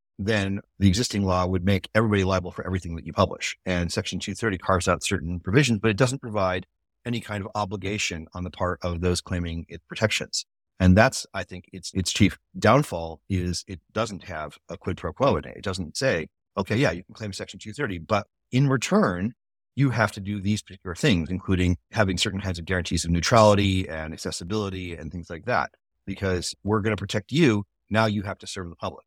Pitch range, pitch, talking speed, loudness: 90-105 Hz, 95 Hz, 210 wpm, -25 LUFS